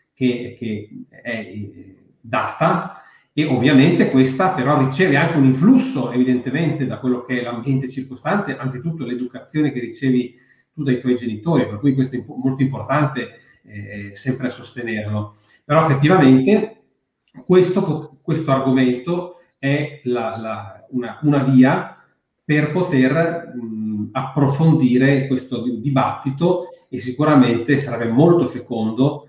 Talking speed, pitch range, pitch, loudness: 115 wpm, 125-150 Hz, 130 Hz, -18 LUFS